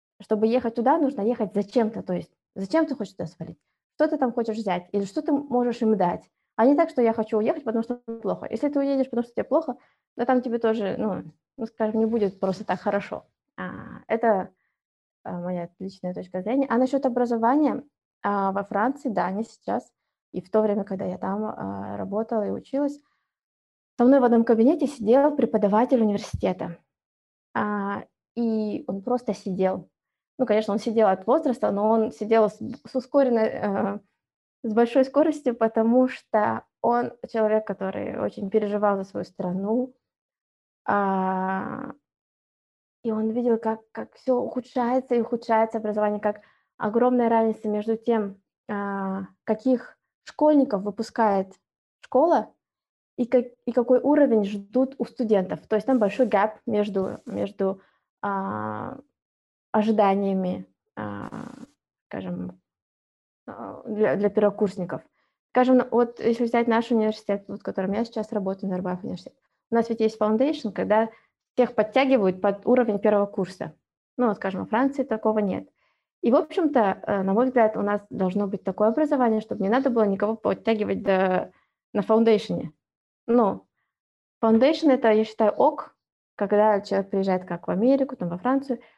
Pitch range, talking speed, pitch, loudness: 200-245 Hz, 150 wpm, 220 Hz, -24 LUFS